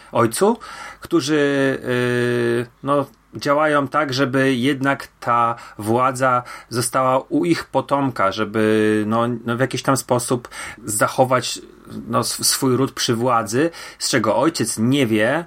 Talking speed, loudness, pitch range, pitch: 125 wpm, -19 LUFS, 120-140 Hz, 130 Hz